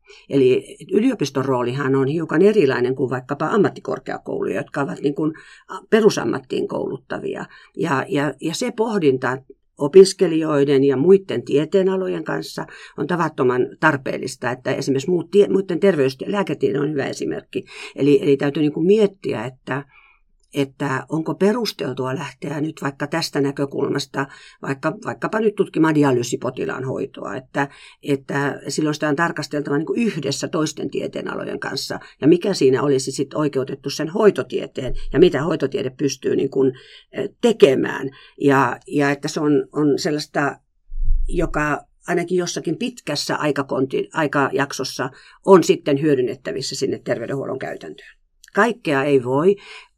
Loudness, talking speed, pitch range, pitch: -20 LUFS, 125 wpm, 135-190 Hz, 150 Hz